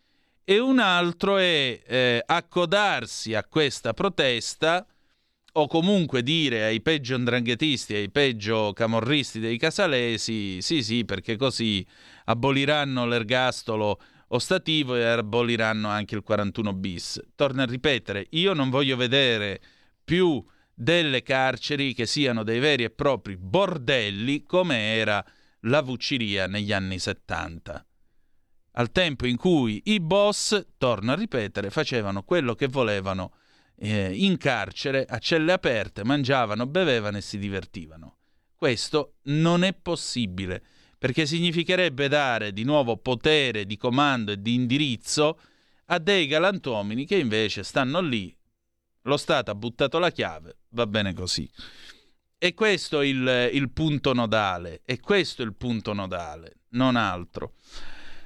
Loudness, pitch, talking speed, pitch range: -24 LUFS, 125 Hz, 130 wpm, 105-155 Hz